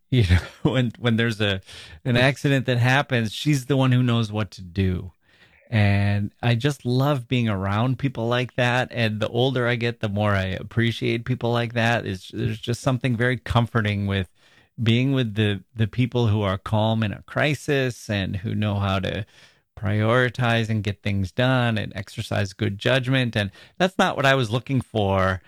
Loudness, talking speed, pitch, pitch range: -23 LUFS, 185 wpm, 115 Hz, 105-125 Hz